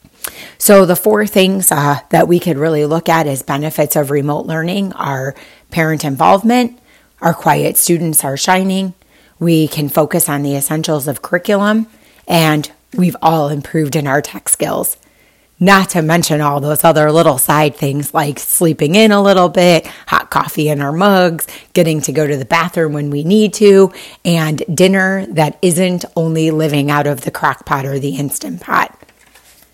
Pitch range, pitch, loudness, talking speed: 150-185 Hz, 160 Hz, -13 LUFS, 170 wpm